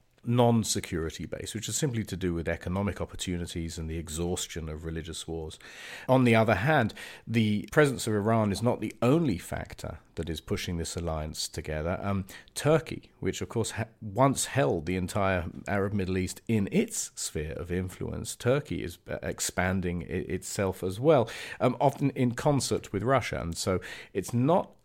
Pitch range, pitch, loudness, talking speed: 85-115 Hz, 95 Hz, -29 LUFS, 170 wpm